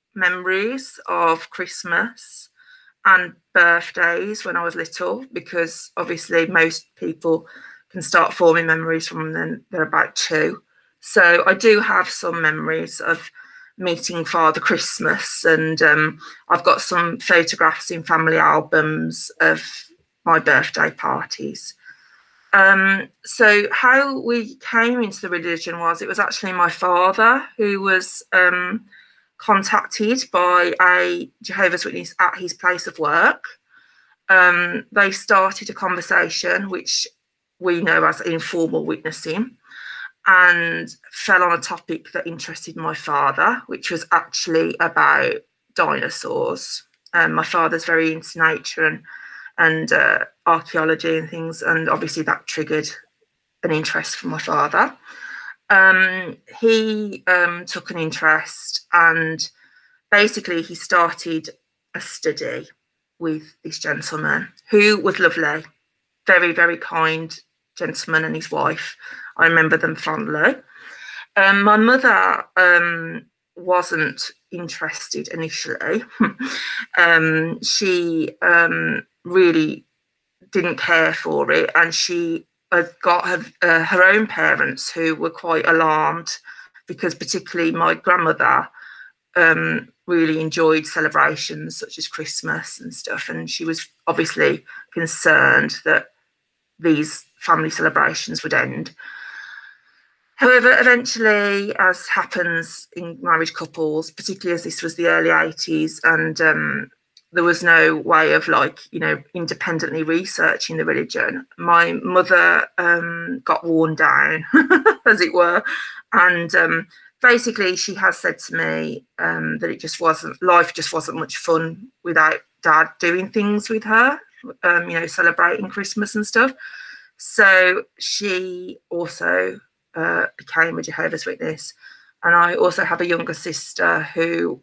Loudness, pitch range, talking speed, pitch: -17 LUFS, 165-225 Hz, 125 wpm, 180 Hz